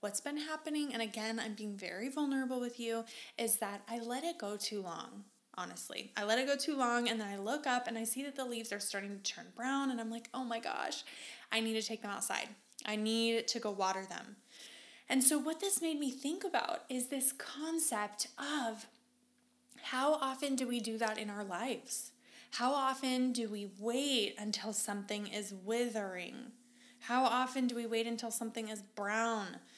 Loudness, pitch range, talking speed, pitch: -36 LUFS, 215-260 Hz, 200 wpm, 230 Hz